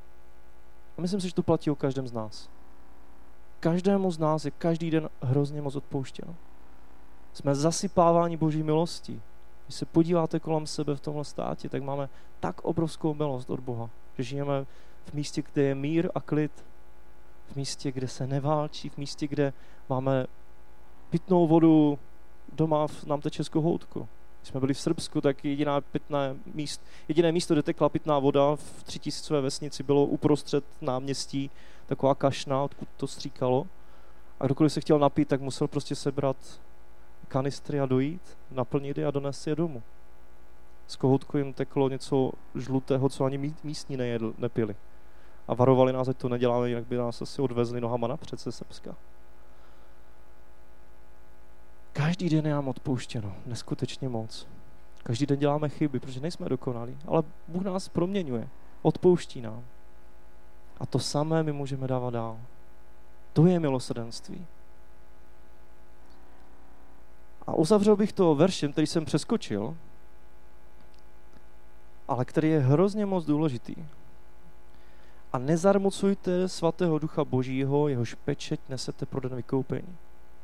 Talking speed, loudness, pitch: 140 wpm, -28 LUFS, 135 Hz